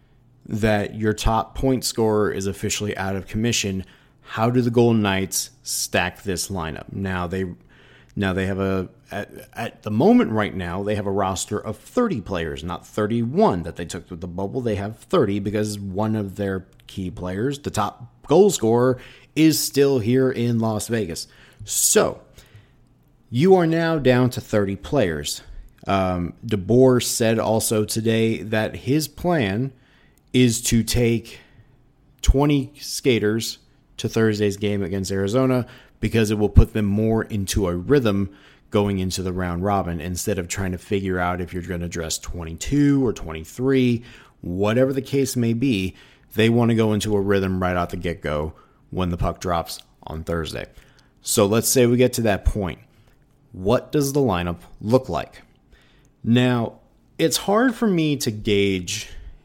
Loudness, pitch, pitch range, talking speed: -22 LUFS, 110 Hz, 95-125 Hz, 165 wpm